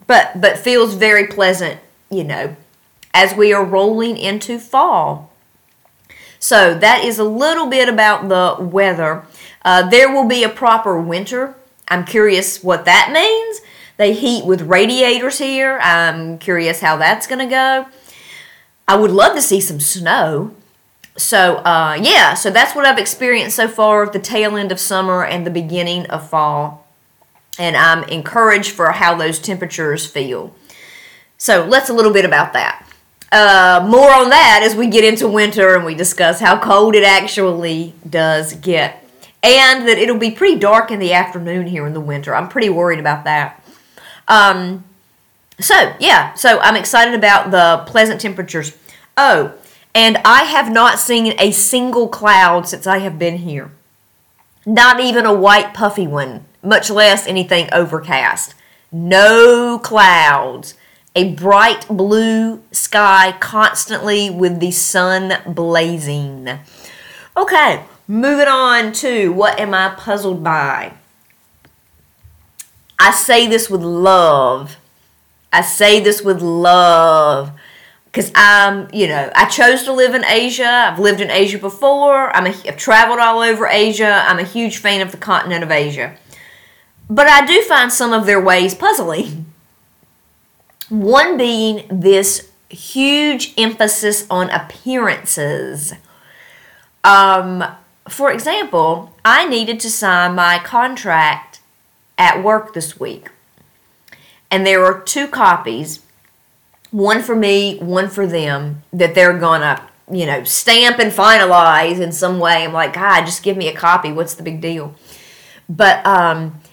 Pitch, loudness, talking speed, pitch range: 195 Hz, -12 LUFS, 145 wpm, 175-225 Hz